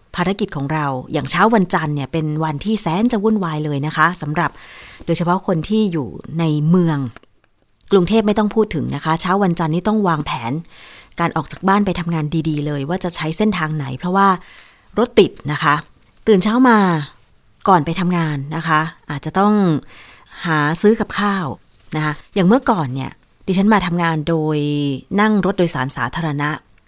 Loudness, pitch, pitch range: -18 LUFS, 165 Hz, 150-195 Hz